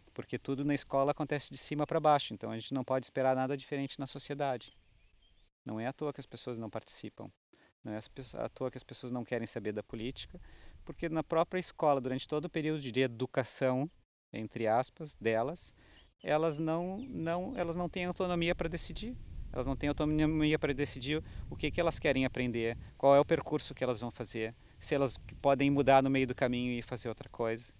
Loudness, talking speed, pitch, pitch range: -34 LUFS, 205 wpm, 135 Hz, 120-150 Hz